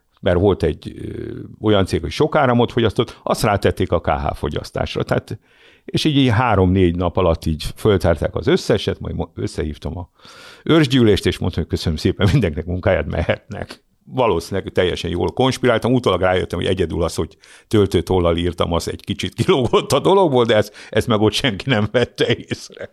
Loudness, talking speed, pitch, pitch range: -18 LUFS, 170 wpm, 105 Hz, 90-125 Hz